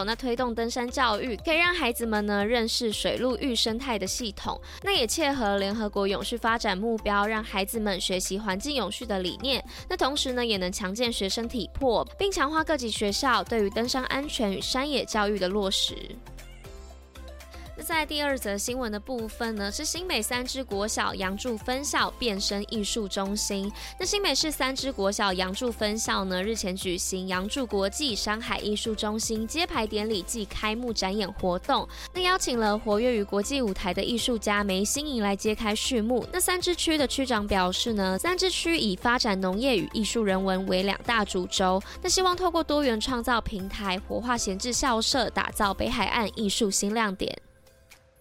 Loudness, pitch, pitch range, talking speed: -27 LUFS, 225 Hz, 200-255 Hz, 280 characters per minute